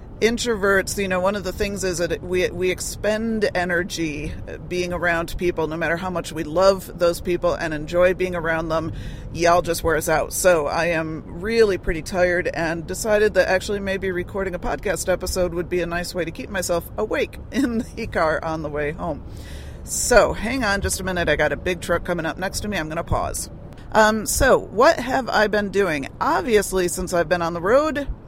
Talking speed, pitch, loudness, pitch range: 210 wpm, 180 Hz, -21 LUFS, 165-195 Hz